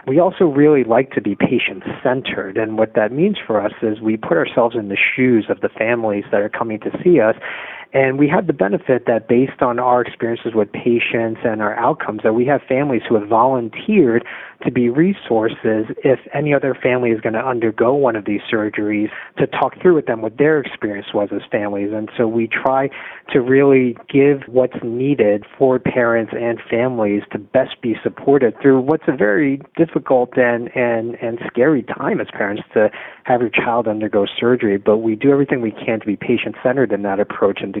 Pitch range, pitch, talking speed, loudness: 110-135 Hz, 120 Hz, 205 wpm, -17 LUFS